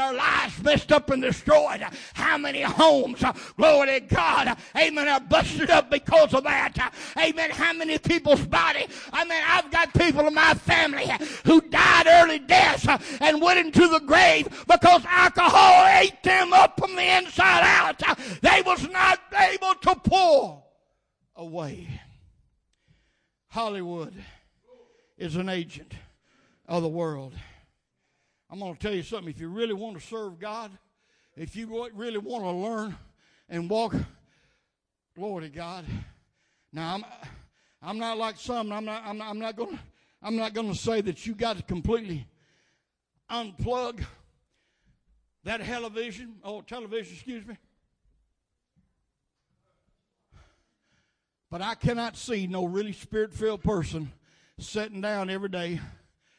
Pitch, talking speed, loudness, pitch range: 230 Hz, 135 wpm, -21 LUFS, 190-315 Hz